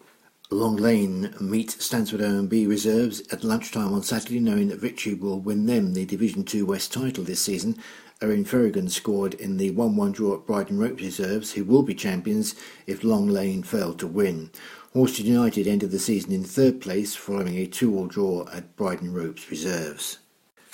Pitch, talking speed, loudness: 120 Hz, 180 wpm, -25 LUFS